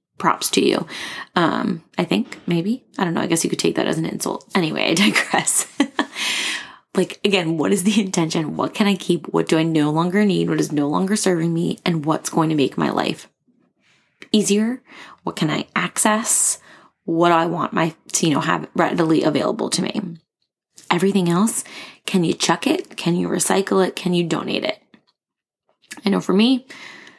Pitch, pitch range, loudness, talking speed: 190 Hz, 170-215 Hz, -20 LUFS, 190 wpm